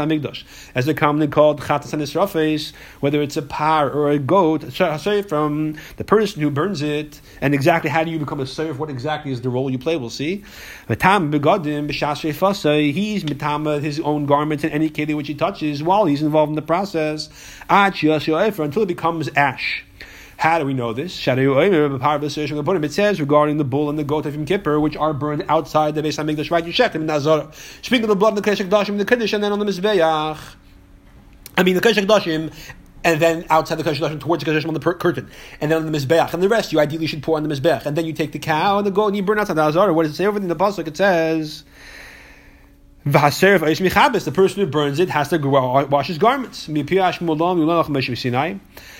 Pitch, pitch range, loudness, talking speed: 155 Hz, 150-175 Hz, -19 LUFS, 195 wpm